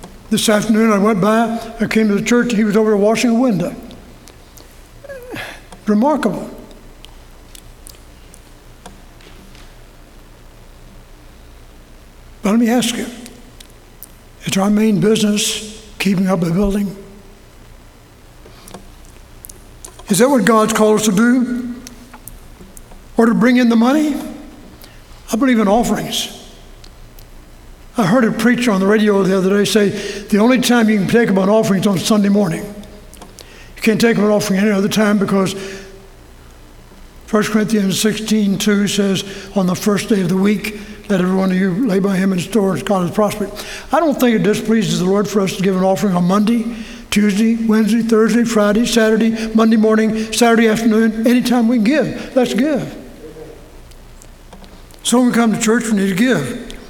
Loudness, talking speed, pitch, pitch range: -15 LUFS, 155 wpm, 210 Hz, 185-225 Hz